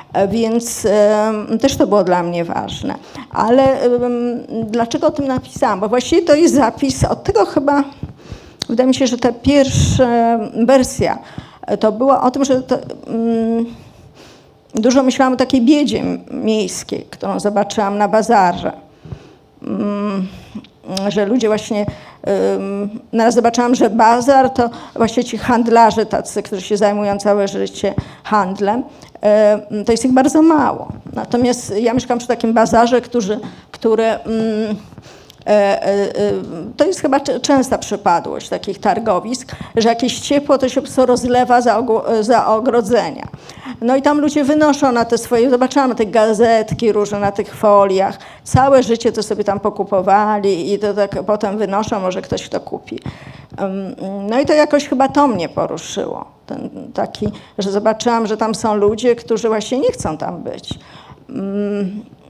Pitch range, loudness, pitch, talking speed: 210-255 Hz, -15 LUFS, 230 Hz, 140 wpm